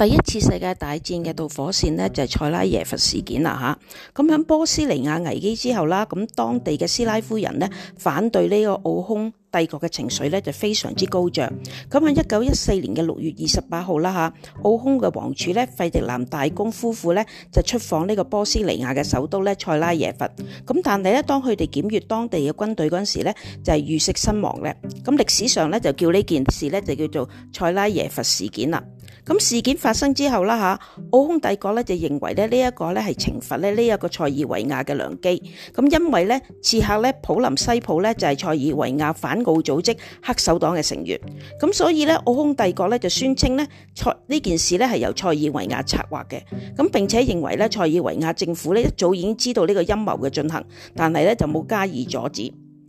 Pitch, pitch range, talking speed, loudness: 185 Hz, 155-225 Hz, 315 characters per minute, -21 LUFS